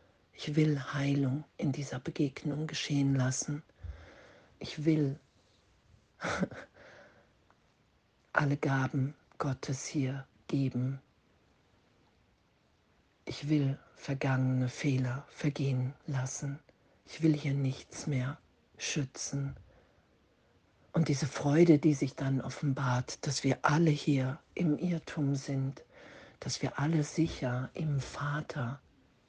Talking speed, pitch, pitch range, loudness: 100 wpm, 140 Hz, 130-150 Hz, -33 LUFS